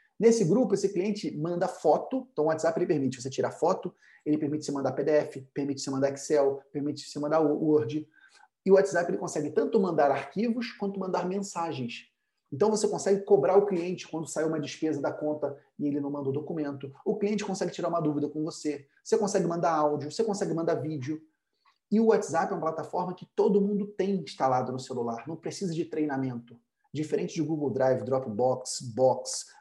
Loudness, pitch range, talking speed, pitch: -29 LUFS, 145-195 Hz, 195 wpm, 155 Hz